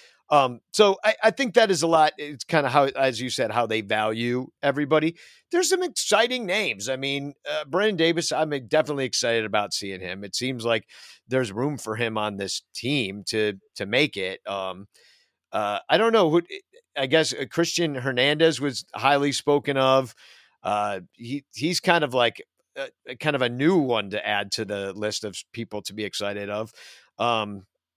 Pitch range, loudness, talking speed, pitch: 110-165 Hz, -24 LUFS, 185 wpm, 135 Hz